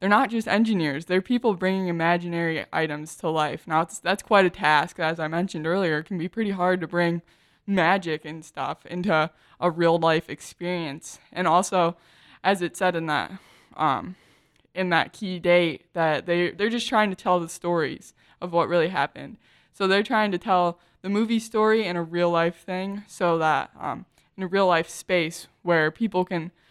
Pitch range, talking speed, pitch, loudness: 160-190 Hz, 190 wpm, 175 Hz, -24 LUFS